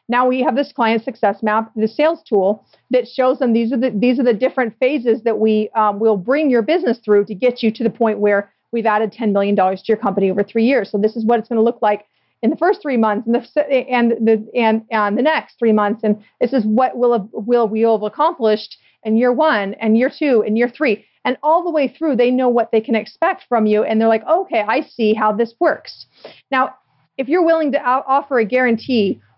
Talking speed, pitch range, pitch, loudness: 250 wpm, 215-255 Hz, 230 Hz, -17 LUFS